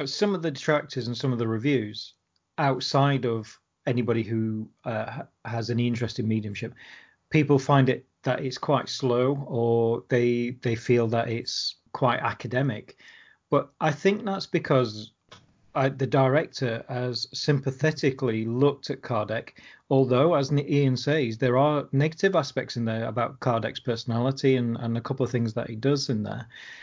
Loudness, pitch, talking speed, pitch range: -26 LUFS, 125 Hz, 160 wpm, 115-140 Hz